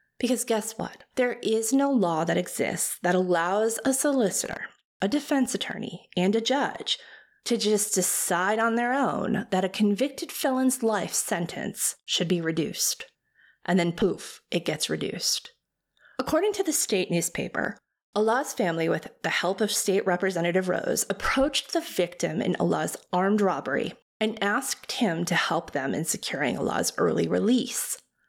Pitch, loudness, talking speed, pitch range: 215 Hz, -26 LUFS, 155 wpm, 185-260 Hz